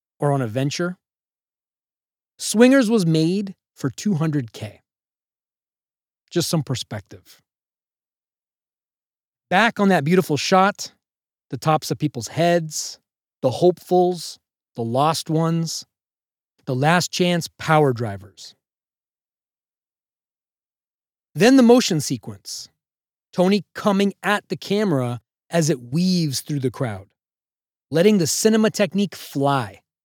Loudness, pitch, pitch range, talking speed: -20 LUFS, 160 Hz, 130-185 Hz, 105 wpm